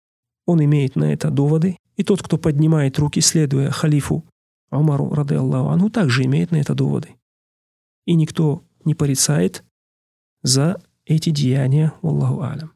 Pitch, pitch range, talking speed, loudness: 150 Hz, 135-160 Hz, 145 wpm, -18 LUFS